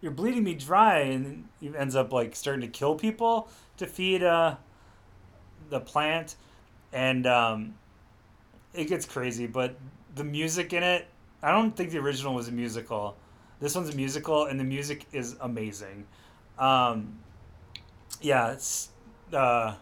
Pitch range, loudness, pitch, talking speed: 110-150 Hz, -28 LUFS, 125 Hz, 150 wpm